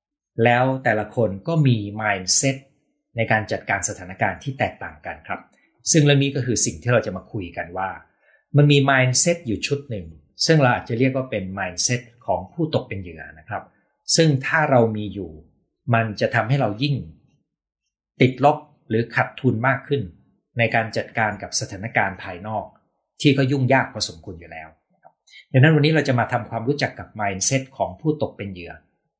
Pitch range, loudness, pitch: 105-135 Hz, -21 LUFS, 120 Hz